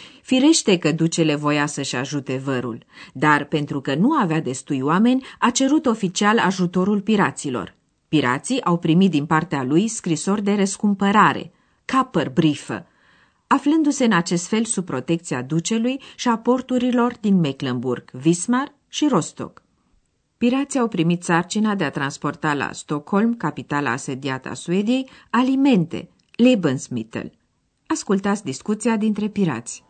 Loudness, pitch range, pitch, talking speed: -20 LUFS, 145-230 Hz, 175 Hz, 130 wpm